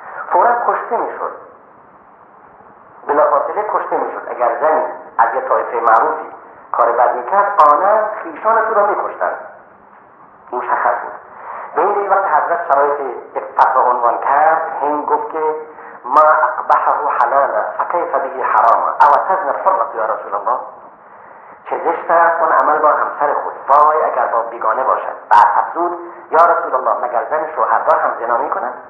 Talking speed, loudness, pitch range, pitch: 145 wpm, -15 LUFS, 140-195 Hz, 160 Hz